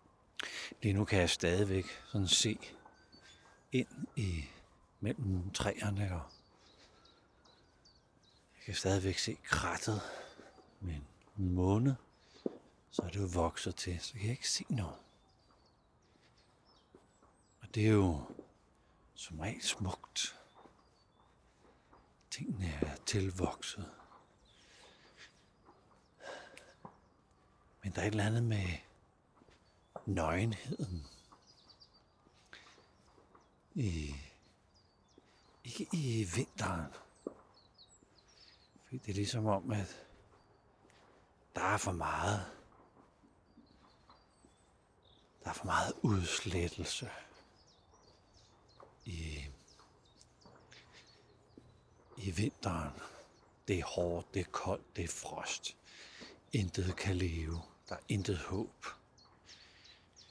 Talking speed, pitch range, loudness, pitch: 90 wpm, 85-105 Hz, -38 LUFS, 95 Hz